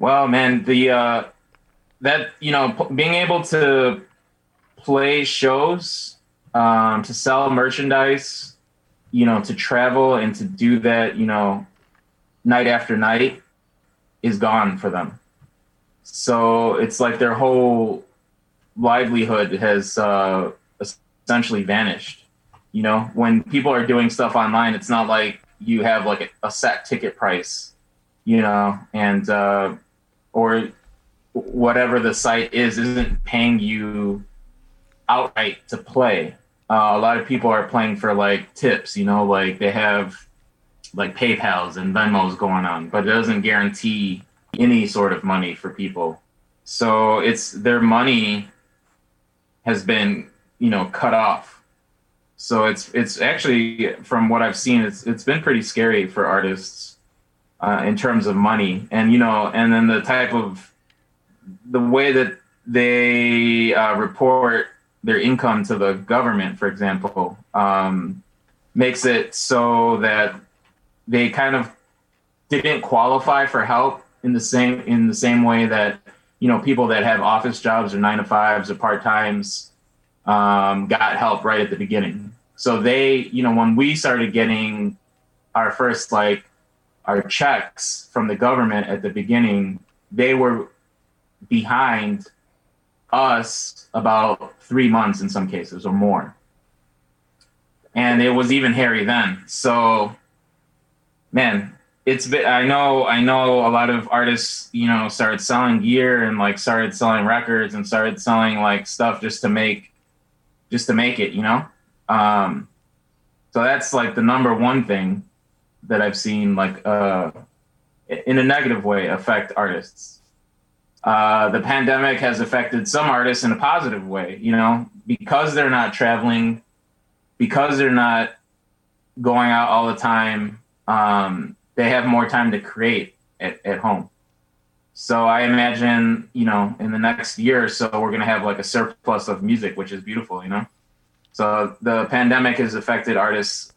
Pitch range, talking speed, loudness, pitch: 100-125 Hz, 150 wpm, -19 LUFS, 115 Hz